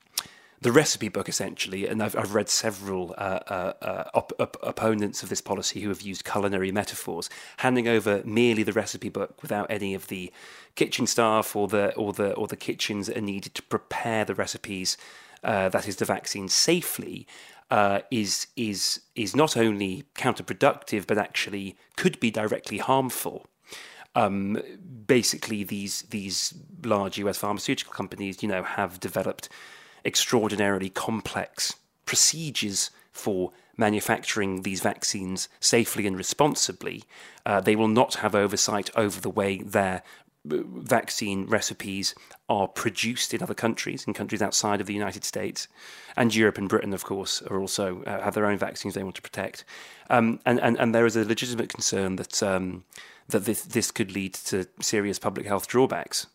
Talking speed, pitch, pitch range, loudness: 160 wpm, 105 Hz, 100-115 Hz, -26 LUFS